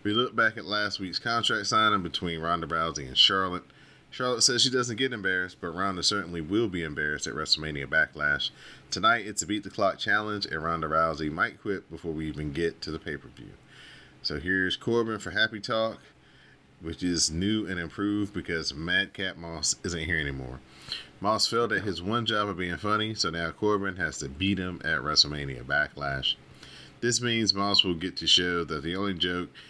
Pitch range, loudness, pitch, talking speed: 80-105 Hz, -27 LUFS, 90 Hz, 190 wpm